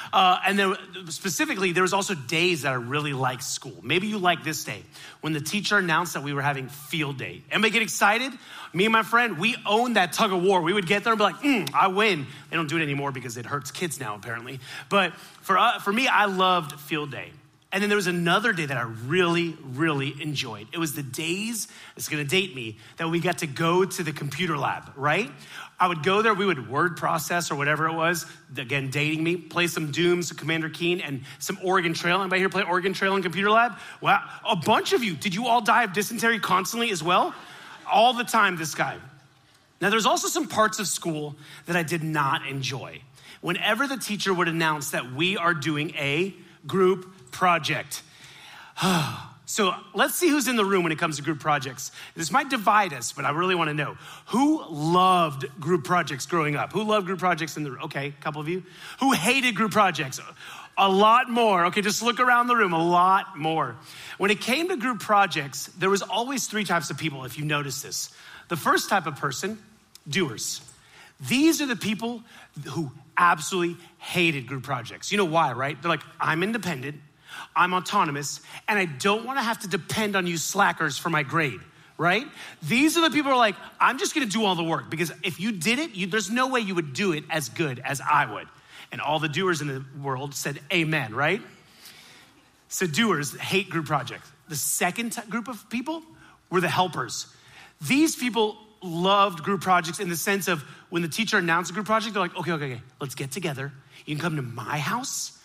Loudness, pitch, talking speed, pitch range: -24 LUFS, 175 Hz, 215 wpm, 150-205 Hz